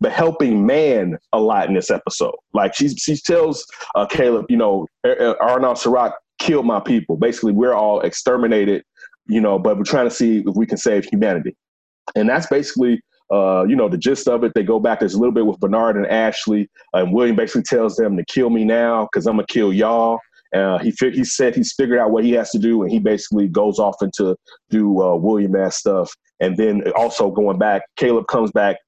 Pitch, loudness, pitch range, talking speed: 115 Hz, -17 LUFS, 105-130 Hz, 220 wpm